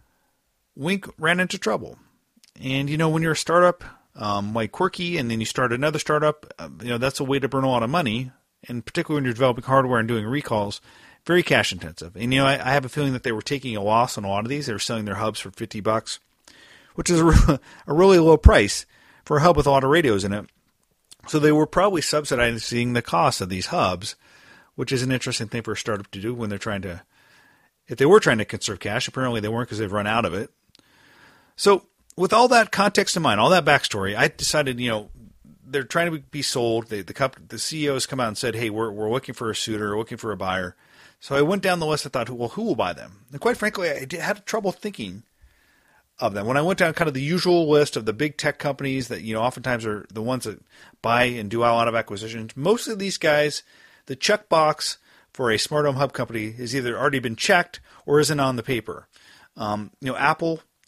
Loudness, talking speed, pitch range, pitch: -22 LUFS, 245 wpm, 110-155 Hz, 130 Hz